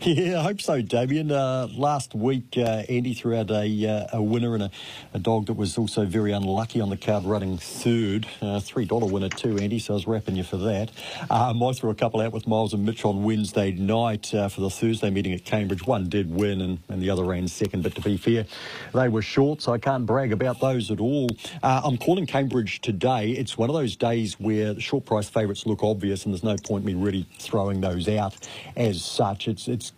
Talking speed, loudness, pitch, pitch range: 230 wpm, -25 LUFS, 110 Hz, 100-120 Hz